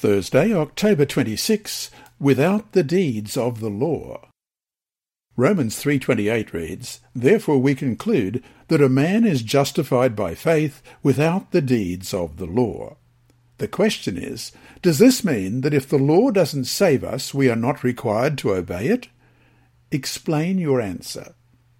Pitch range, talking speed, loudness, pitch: 115-160 Hz, 140 wpm, -20 LUFS, 135 Hz